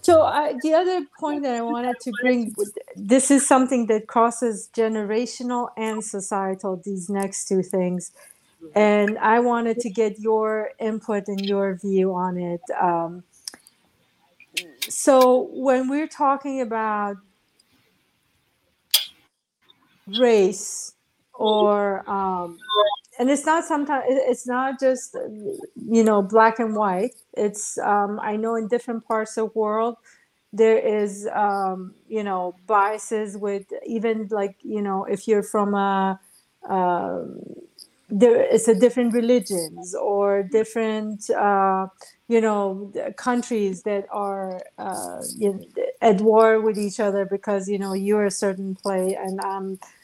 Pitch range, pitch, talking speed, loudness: 200-240 Hz, 215 Hz, 130 wpm, -22 LUFS